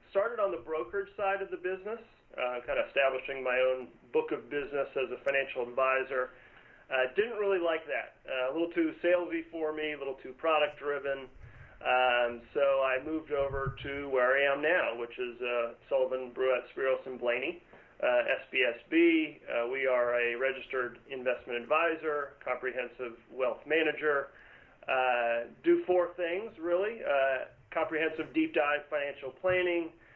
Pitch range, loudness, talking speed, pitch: 130-170 Hz, -31 LUFS, 160 wpm, 140 Hz